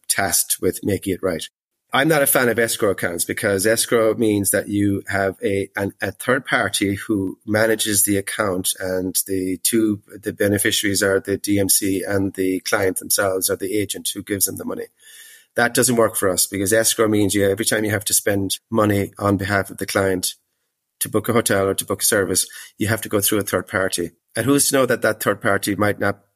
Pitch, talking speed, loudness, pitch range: 100 Hz, 215 wpm, -19 LUFS, 95-110 Hz